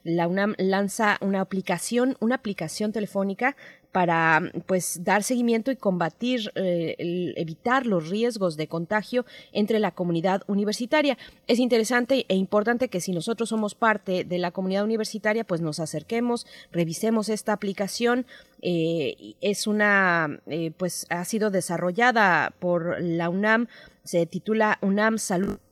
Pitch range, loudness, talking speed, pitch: 175-225 Hz, -25 LUFS, 135 wpm, 200 Hz